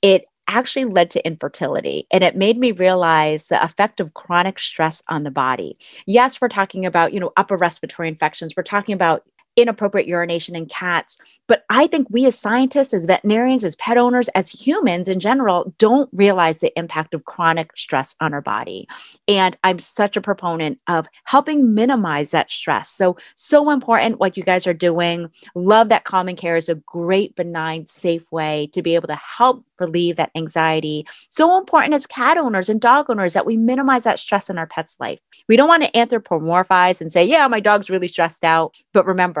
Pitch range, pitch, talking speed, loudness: 165-230 Hz, 185 Hz, 195 wpm, -17 LUFS